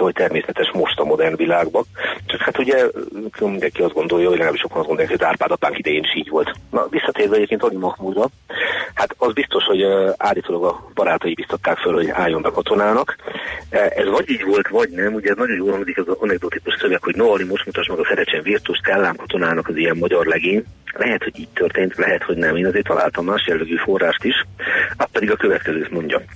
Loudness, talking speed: -18 LUFS, 205 wpm